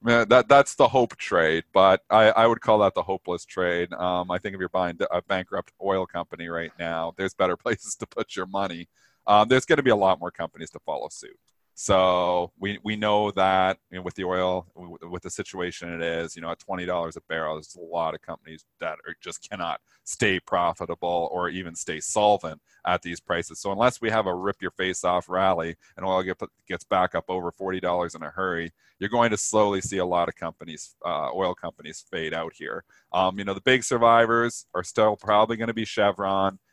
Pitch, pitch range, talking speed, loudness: 95 Hz, 85-105 Hz, 215 wpm, -24 LUFS